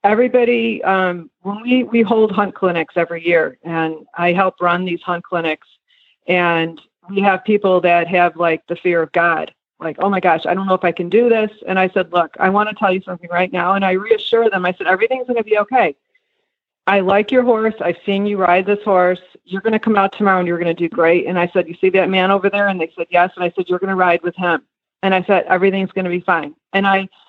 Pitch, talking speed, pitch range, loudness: 185 Hz, 240 wpm, 175-205 Hz, -16 LUFS